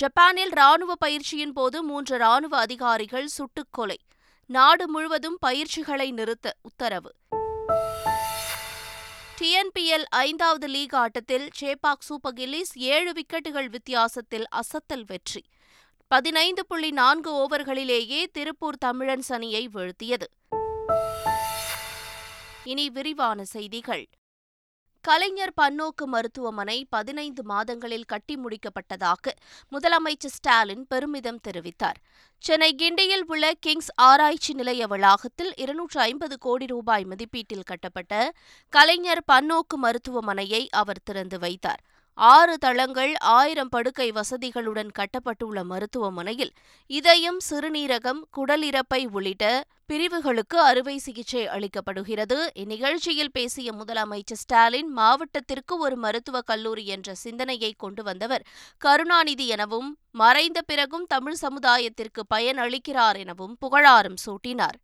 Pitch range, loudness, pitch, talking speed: 225-300 Hz, -23 LUFS, 260 Hz, 95 wpm